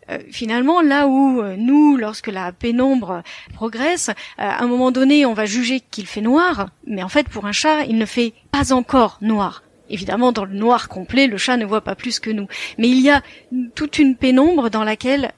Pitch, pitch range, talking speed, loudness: 245 Hz, 215-275 Hz, 215 wpm, -17 LUFS